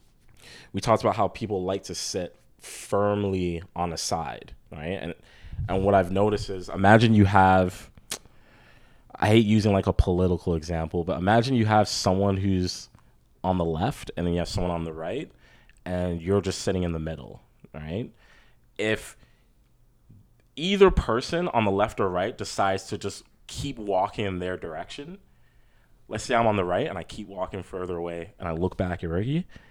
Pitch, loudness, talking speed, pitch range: 95 Hz, -25 LUFS, 180 wpm, 90-105 Hz